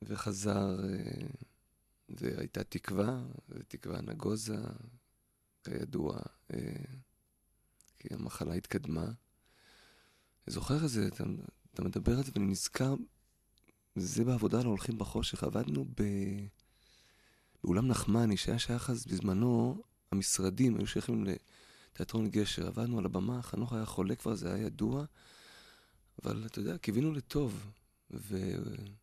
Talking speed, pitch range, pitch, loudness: 110 wpm, 100-120 Hz, 110 Hz, -36 LUFS